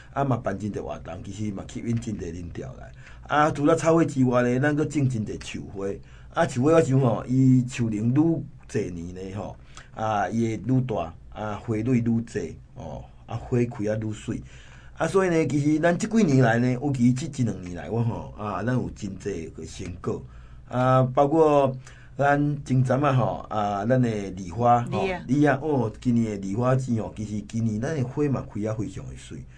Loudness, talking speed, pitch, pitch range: -25 LUFS, 265 characters per minute, 125 Hz, 105-135 Hz